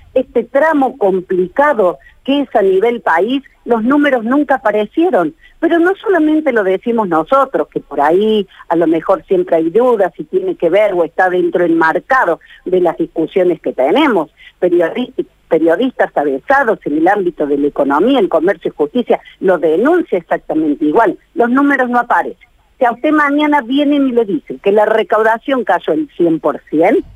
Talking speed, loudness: 170 wpm, -13 LUFS